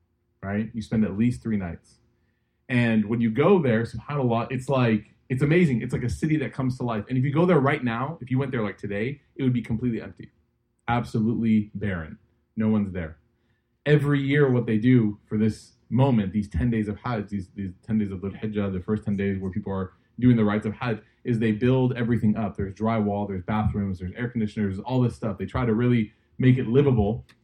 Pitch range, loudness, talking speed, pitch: 105-125 Hz, -25 LUFS, 225 wpm, 115 Hz